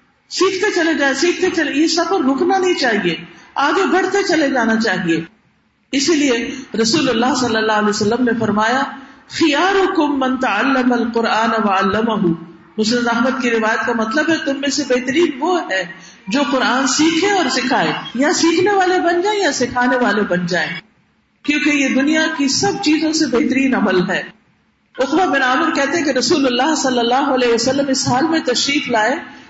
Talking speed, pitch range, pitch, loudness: 170 wpm, 230-315 Hz, 265 Hz, -16 LUFS